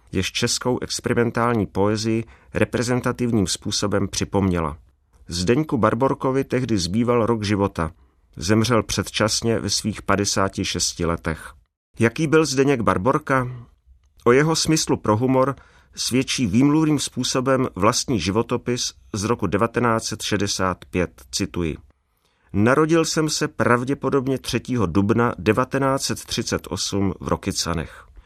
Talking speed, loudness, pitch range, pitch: 100 wpm, -21 LUFS, 95-125 Hz, 110 Hz